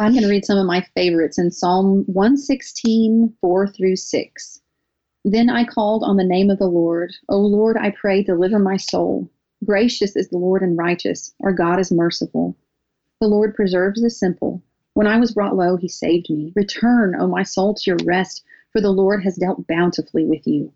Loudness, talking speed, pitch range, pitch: -18 LUFS, 195 wpm, 180-210 Hz, 195 Hz